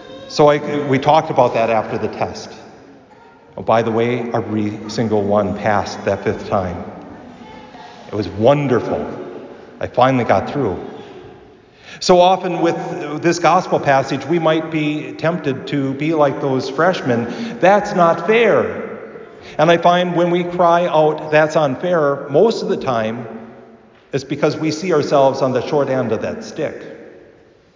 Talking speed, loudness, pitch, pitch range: 150 wpm, -17 LUFS, 145 Hz, 115-170 Hz